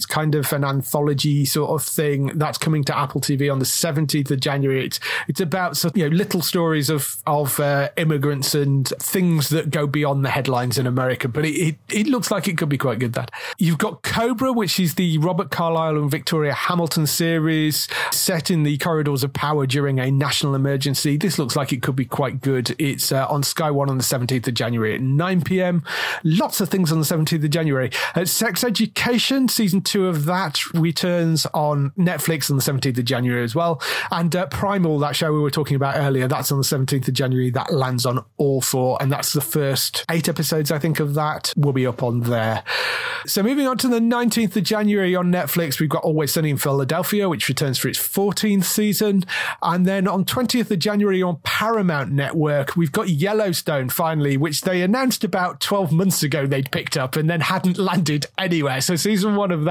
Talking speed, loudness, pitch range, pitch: 210 wpm, -20 LUFS, 140-180 Hz, 155 Hz